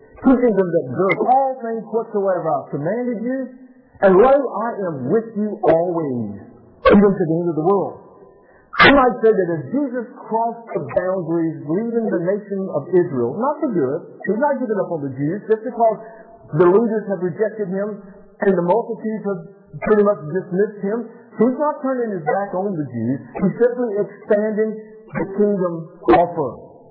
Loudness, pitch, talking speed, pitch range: -19 LUFS, 205 Hz, 175 wpm, 180-230 Hz